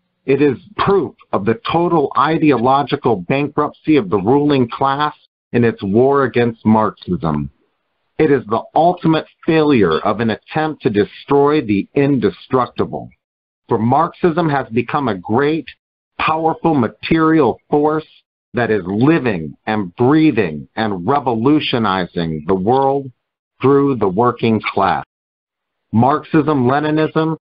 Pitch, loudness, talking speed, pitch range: 135 Hz, -16 LUFS, 115 wpm, 110-155 Hz